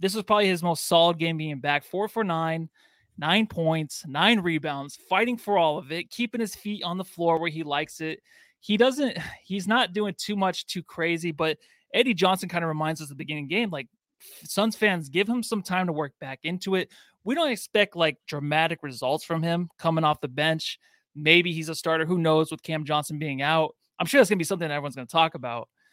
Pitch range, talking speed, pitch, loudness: 155-205 Hz, 230 wpm, 170 Hz, -25 LUFS